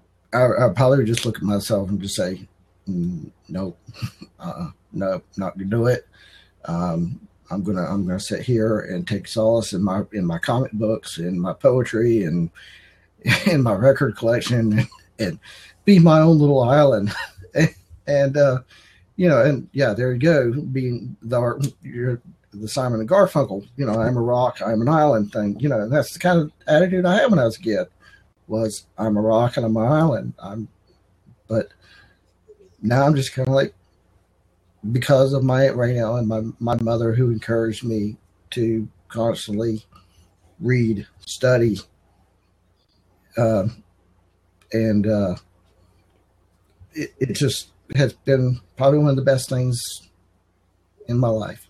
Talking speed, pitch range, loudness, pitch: 160 wpm, 95-130 Hz, -20 LUFS, 115 Hz